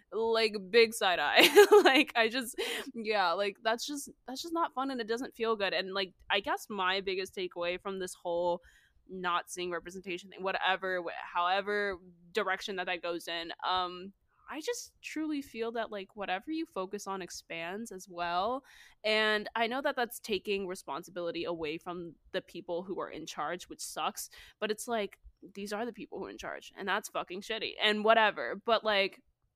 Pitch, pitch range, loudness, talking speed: 200 Hz, 180-230 Hz, -32 LUFS, 185 wpm